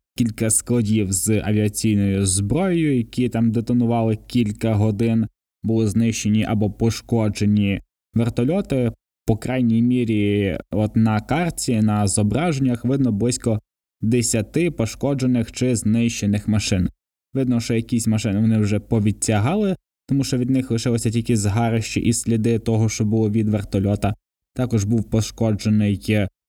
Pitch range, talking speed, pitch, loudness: 105-120 Hz, 120 wpm, 115 Hz, -20 LUFS